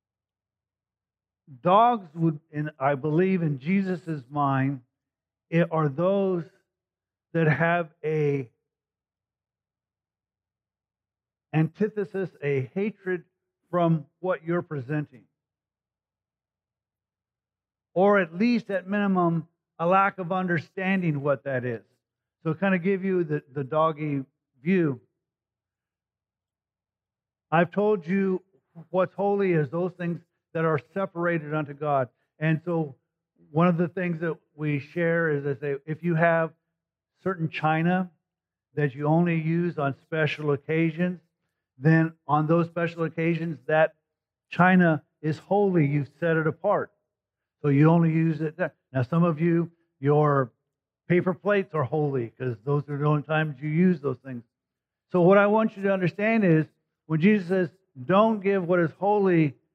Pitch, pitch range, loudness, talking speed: 160 Hz, 140-175 Hz, -25 LUFS, 135 wpm